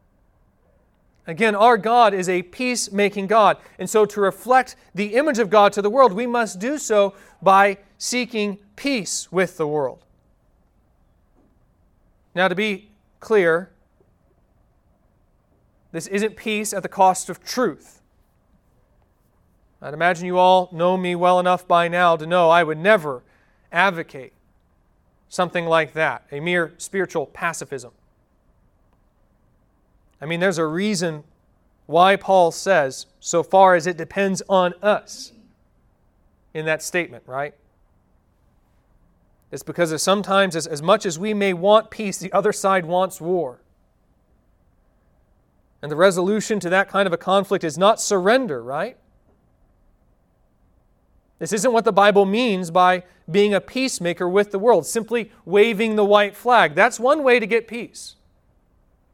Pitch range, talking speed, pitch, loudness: 160-210 Hz, 140 wpm, 185 Hz, -19 LUFS